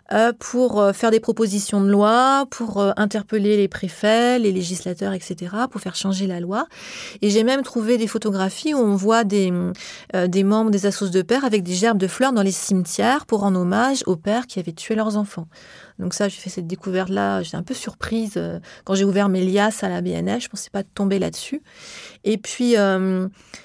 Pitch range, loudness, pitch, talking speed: 190-225 Hz, -20 LUFS, 205 Hz, 215 wpm